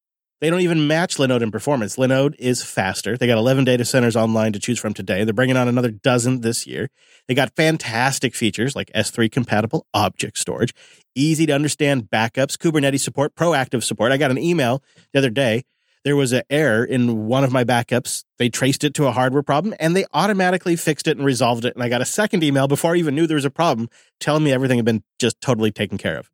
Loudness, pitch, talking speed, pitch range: -19 LUFS, 130 Hz, 225 wpm, 120-150 Hz